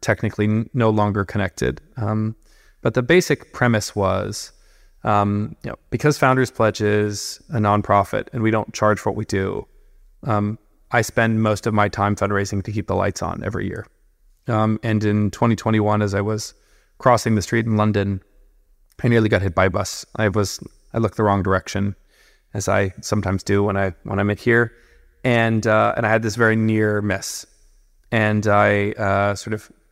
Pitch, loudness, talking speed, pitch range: 105 Hz, -20 LUFS, 185 wpm, 100-110 Hz